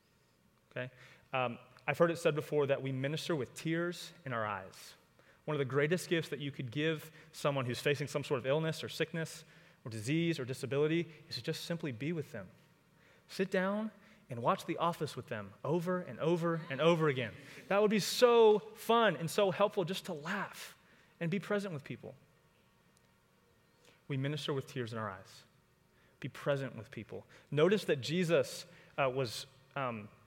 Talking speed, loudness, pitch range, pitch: 180 wpm, -35 LUFS, 135-170 Hz, 155 Hz